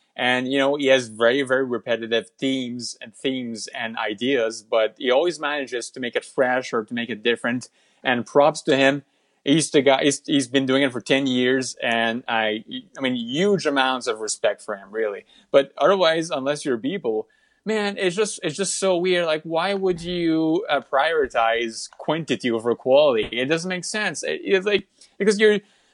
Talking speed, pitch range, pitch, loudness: 190 wpm, 125-190 Hz, 140 Hz, -22 LUFS